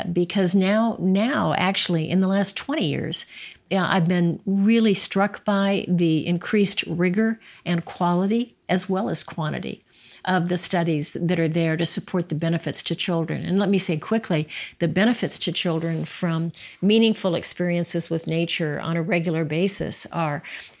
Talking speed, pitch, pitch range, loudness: 155 wpm, 175 Hz, 165-195 Hz, -23 LUFS